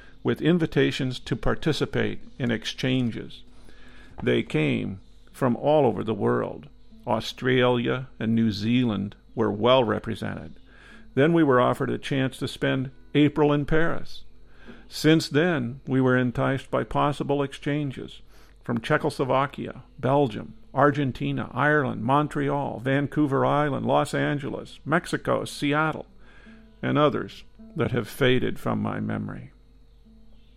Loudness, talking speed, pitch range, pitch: -25 LUFS, 115 wpm, 120-145 Hz, 135 Hz